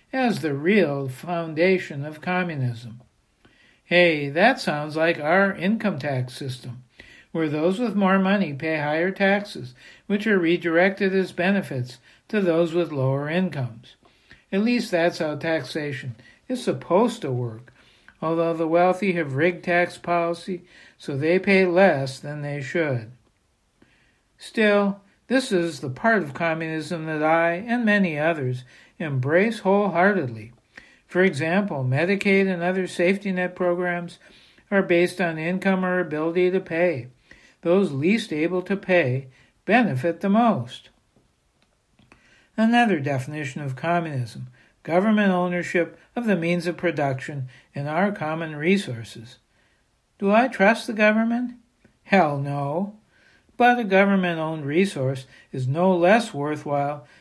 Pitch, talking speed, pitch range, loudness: 170 Hz, 130 wpm, 145-195 Hz, -22 LUFS